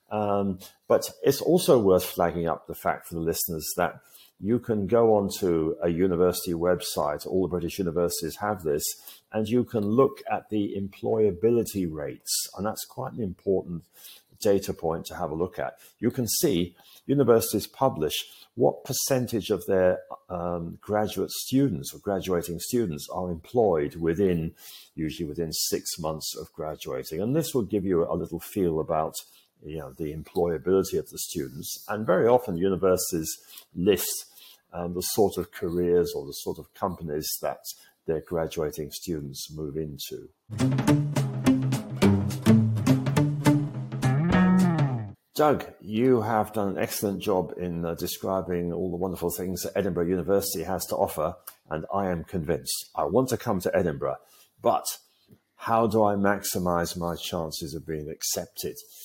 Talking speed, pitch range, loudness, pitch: 150 wpm, 85-115 Hz, -27 LUFS, 95 Hz